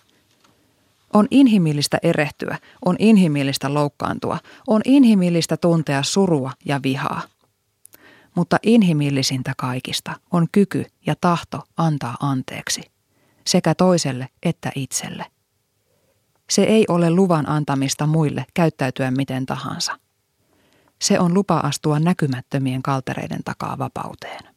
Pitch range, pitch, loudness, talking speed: 135-175 Hz, 150 Hz, -20 LUFS, 105 wpm